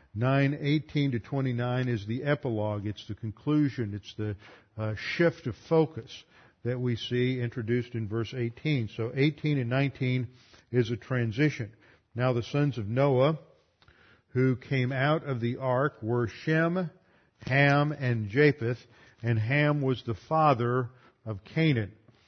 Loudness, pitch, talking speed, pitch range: -29 LUFS, 125 Hz, 145 wpm, 115-140 Hz